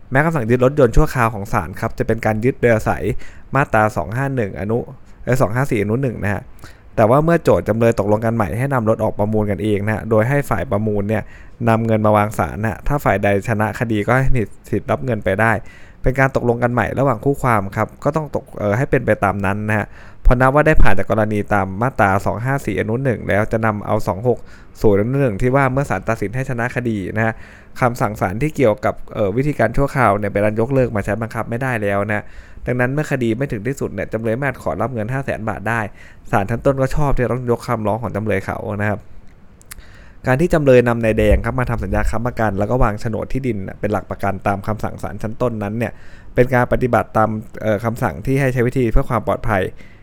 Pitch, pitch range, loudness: 110 Hz, 105-125 Hz, -18 LUFS